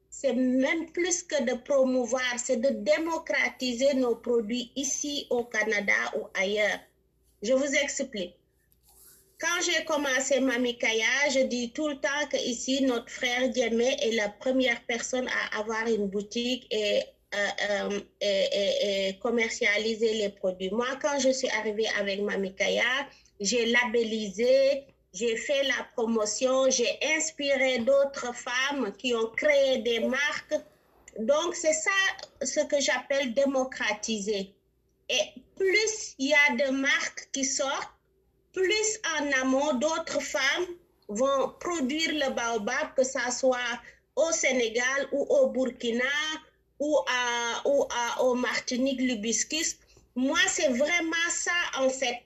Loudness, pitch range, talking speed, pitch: -27 LUFS, 235-290 Hz, 135 wpm, 260 Hz